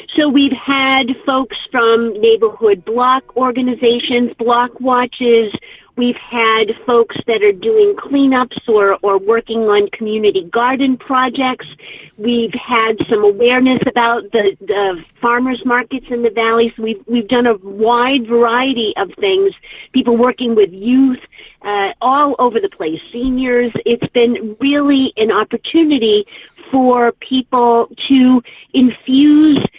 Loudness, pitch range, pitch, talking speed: -14 LUFS, 230-265 Hz, 245 Hz, 130 wpm